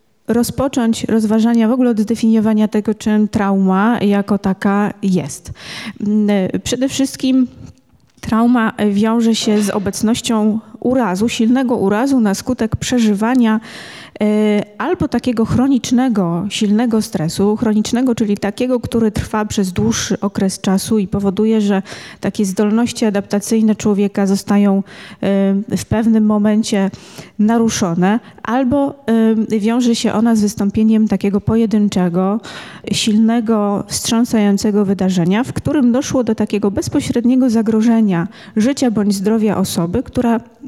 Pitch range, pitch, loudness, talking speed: 205-230 Hz, 220 Hz, -15 LUFS, 115 wpm